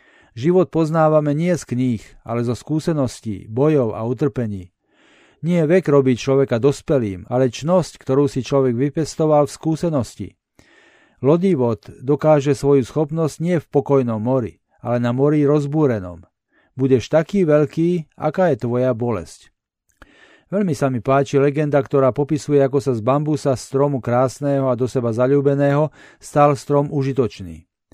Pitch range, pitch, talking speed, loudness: 125-150 Hz, 140 Hz, 135 wpm, -19 LUFS